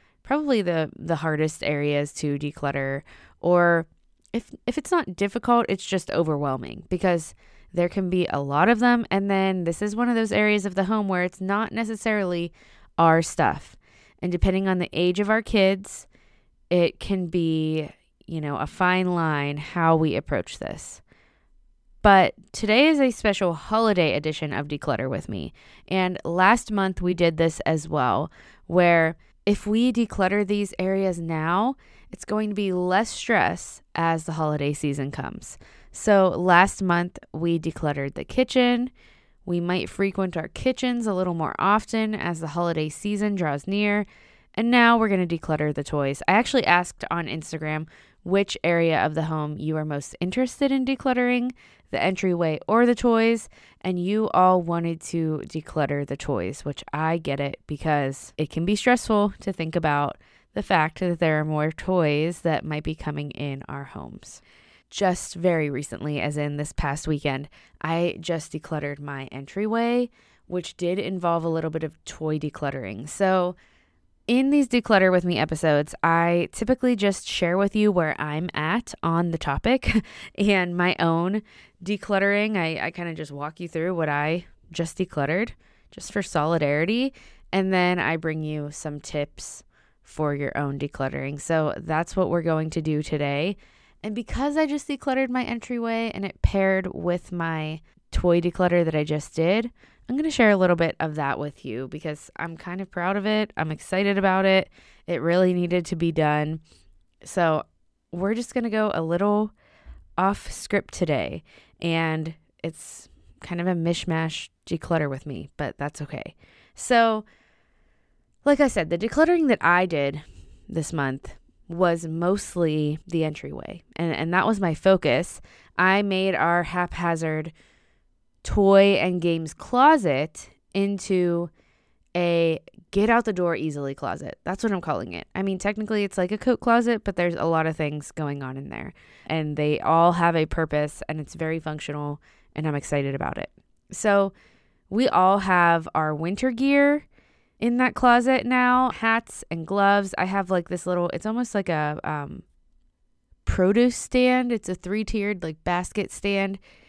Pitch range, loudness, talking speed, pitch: 155-205 Hz, -24 LUFS, 170 wpm, 175 Hz